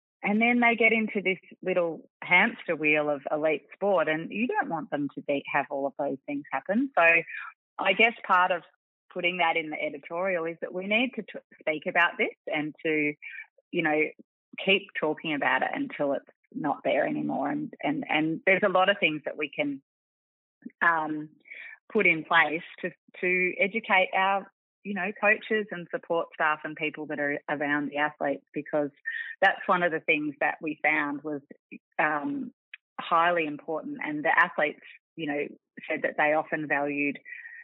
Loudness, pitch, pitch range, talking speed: -27 LUFS, 170 Hz, 150-200 Hz, 180 wpm